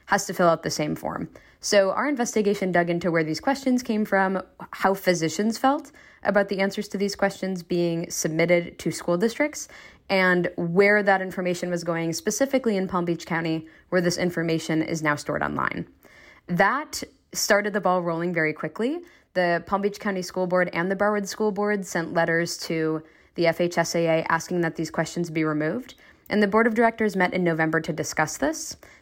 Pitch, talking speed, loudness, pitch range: 180 Hz, 185 wpm, -24 LUFS, 165-205 Hz